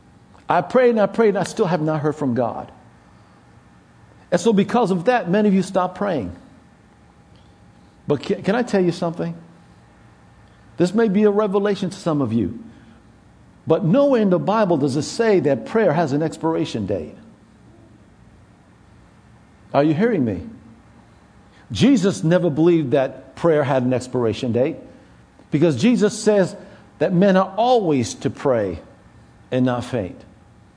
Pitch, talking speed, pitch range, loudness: 175 Hz, 150 wpm, 135-205 Hz, -19 LUFS